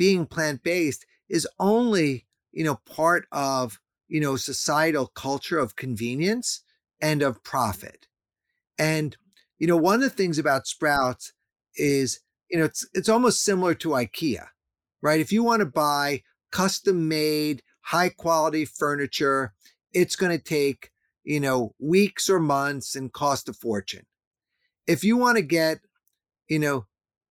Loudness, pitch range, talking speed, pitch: -24 LUFS, 135-180 Hz, 145 wpm, 155 Hz